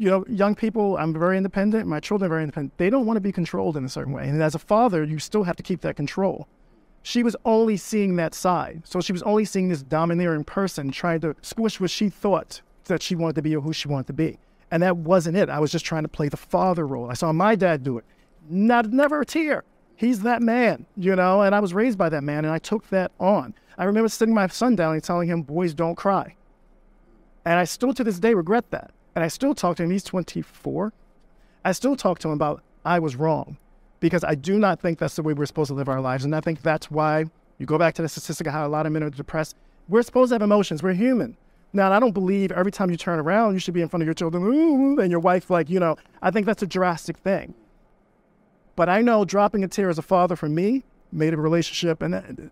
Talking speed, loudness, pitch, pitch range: 260 wpm, -23 LUFS, 180 Hz, 160-205 Hz